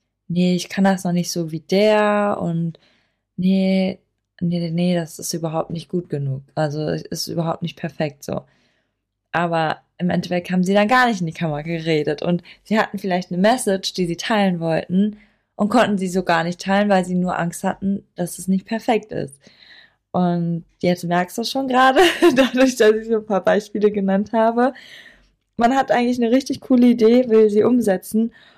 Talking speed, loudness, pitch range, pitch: 190 wpm, -19 LUFS, 170-215 Hz, 190 Hz